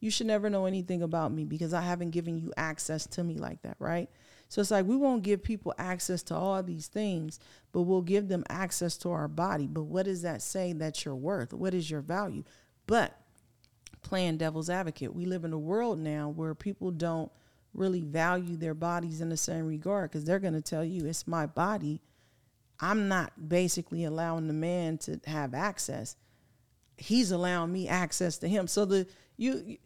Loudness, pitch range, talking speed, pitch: -32 LUFS, 155-190 Hz, 195 wpm, 170 Hz